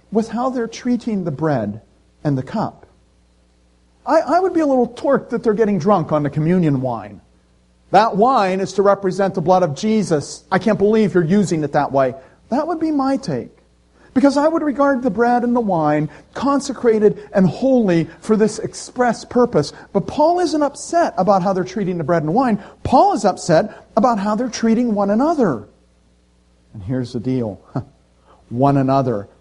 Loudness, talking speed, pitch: -17 LUFS, 180 wpm, 195 Hz